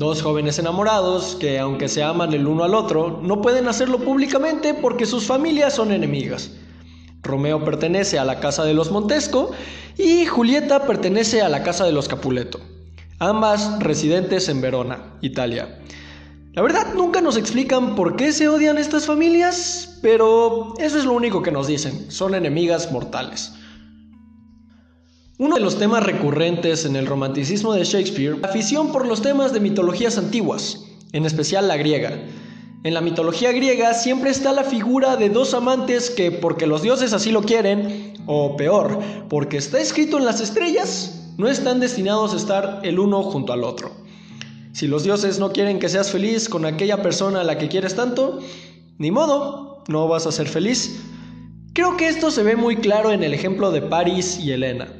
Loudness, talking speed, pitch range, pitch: -19 LUFS, 175 wpm, 155-245 Hz, 195 Hz